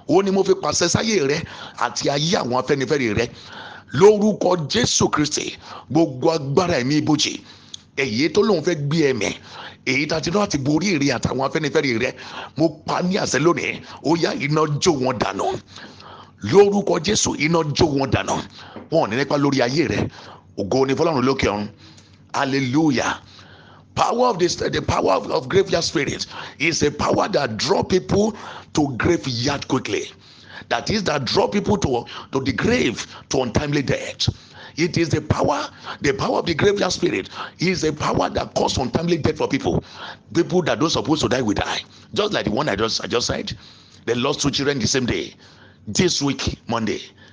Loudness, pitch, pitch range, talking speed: -20 LUFS, 155 Hz, 130-175 Hz, 170 wpm